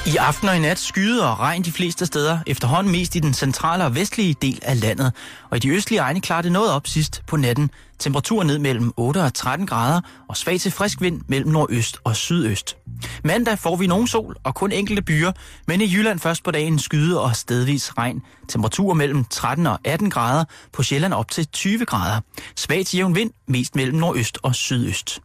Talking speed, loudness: 210 wpm, -20 LUFS